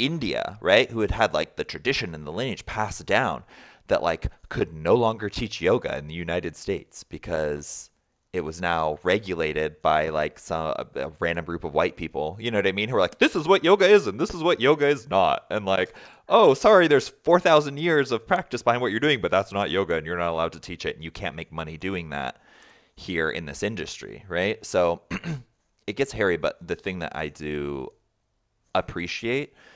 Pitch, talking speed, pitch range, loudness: 100 Hz, 215 wpm, 85-120 Hz, -24 LUFS